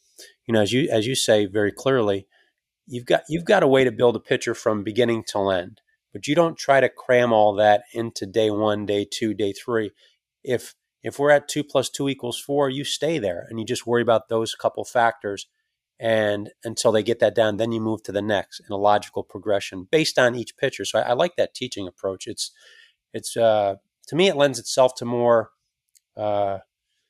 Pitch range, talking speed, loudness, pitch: 105-135 Hz, 215 wpm, -22 LUFS, 115 Hz